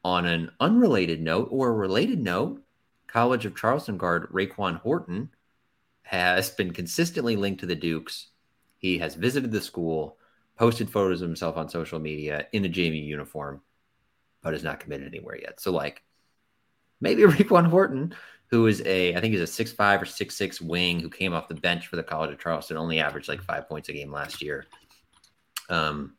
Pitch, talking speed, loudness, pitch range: 90 Hz, 185 wpm, -26 LUFS, 80-105 Hz